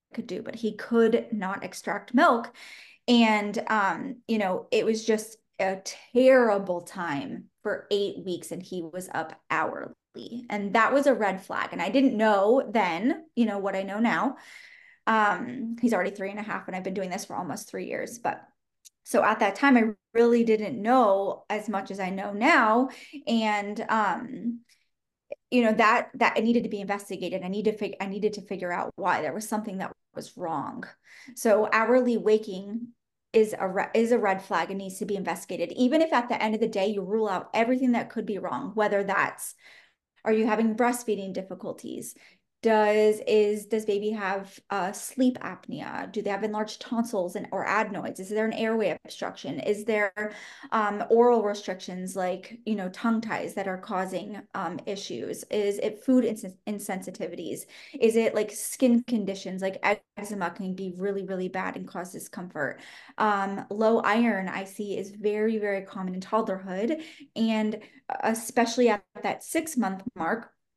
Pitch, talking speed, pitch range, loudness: 215 Hz, 180 wpm, 195-230 Hz, -27 LUFS